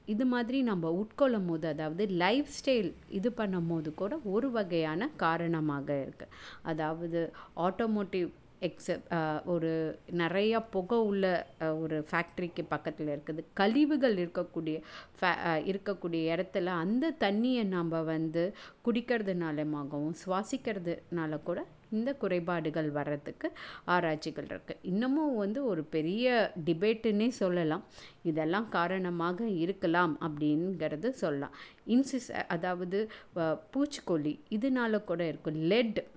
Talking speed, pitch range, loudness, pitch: 100 wpm, 160-215 Hz, -33 LUFS, 175 Hz